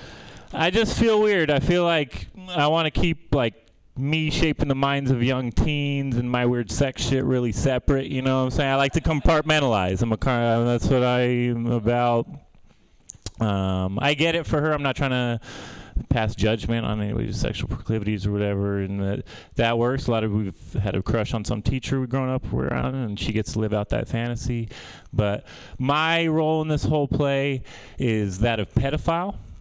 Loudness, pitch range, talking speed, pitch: -23 LUFS, 110-145 Hz, 200 wpm, 125 Hz